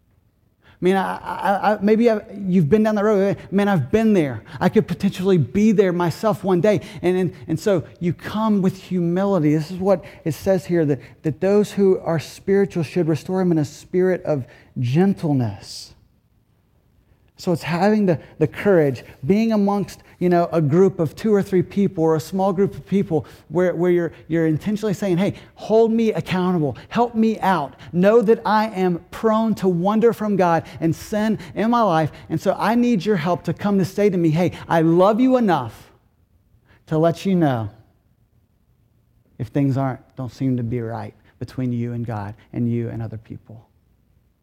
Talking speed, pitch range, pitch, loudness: 190 wpm, 130-195 Hz, 170 Hz, -20 LUFS